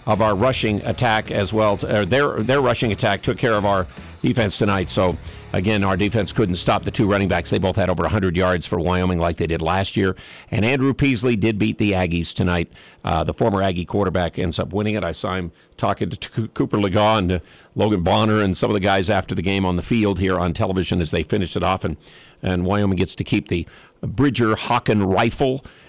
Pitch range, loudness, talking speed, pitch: 90-110 Hz, -20 LUFS, 225 wpm, 100 Hz